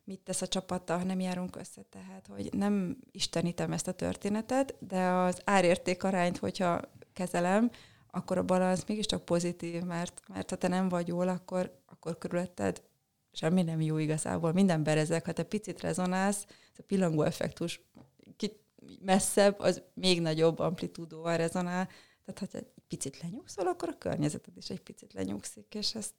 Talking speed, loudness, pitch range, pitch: 165 wpm, -32 LUFS, 170-195 Hz, 180 Hz